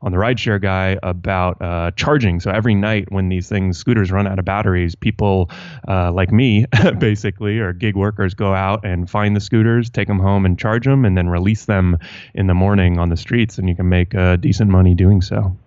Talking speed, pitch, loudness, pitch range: 220 wpm, 100 Hz, -16 LUFS, 90-110 Hz